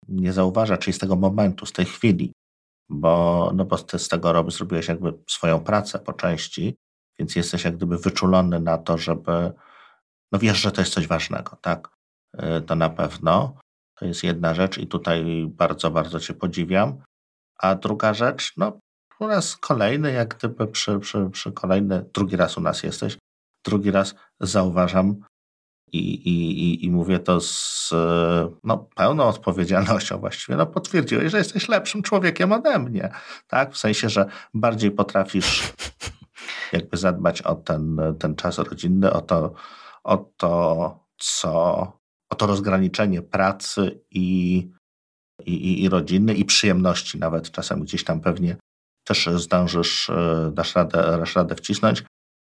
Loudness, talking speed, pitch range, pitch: -22 LUFS, 150 wpm, 85-100 Hz, 90 Hz